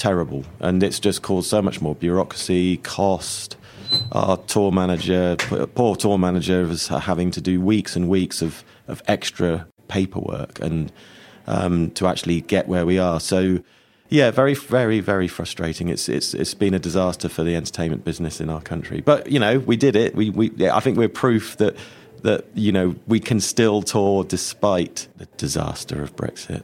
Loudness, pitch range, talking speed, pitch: -21 LUFS, 85-105 Hz, 180 wpm, 95 Hz